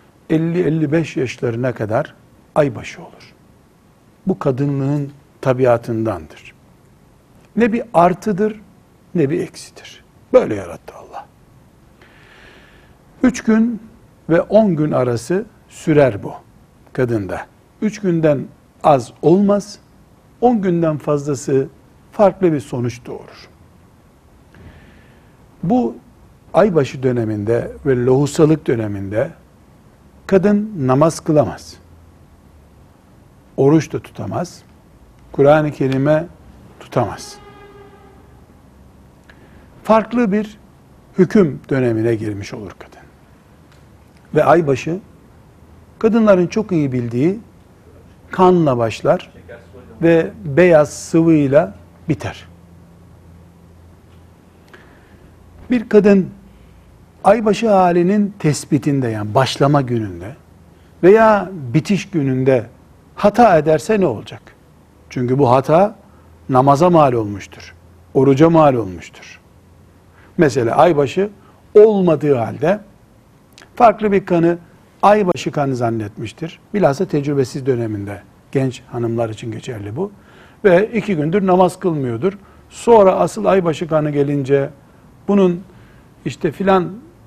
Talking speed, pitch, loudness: 85 wpm, 140 Hz, -16 LUFS